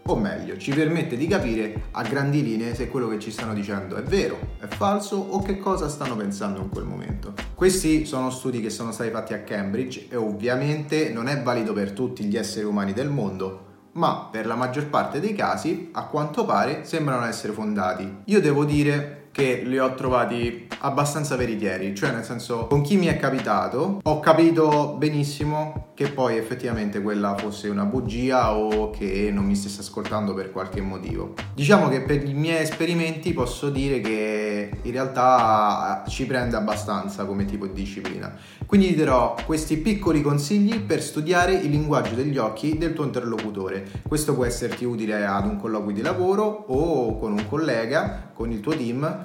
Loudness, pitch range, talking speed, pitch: -24 LUFS, 105-150 Hz, 180 wpm, 125 Hz